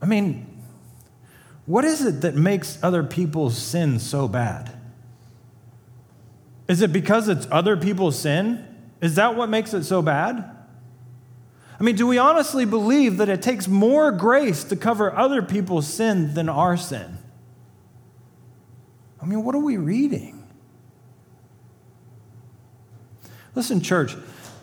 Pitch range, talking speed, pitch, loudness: 120-205 Hz, 130 wpm, 150 Hz, -21 LUFS